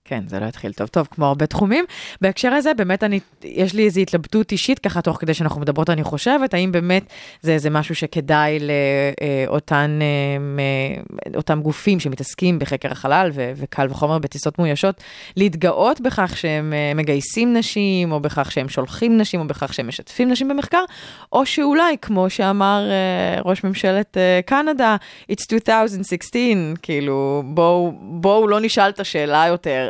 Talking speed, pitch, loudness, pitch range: 150 wpm, 175 Hz, -19 LUFS, 150-205 Hz